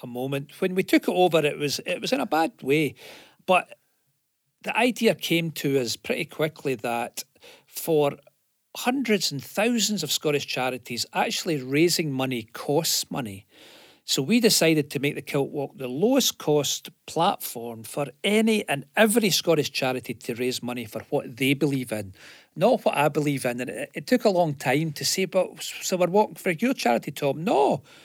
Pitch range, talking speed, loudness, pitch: 130-190 Hz, 180 wpm, -24 LUFS, 145 Hz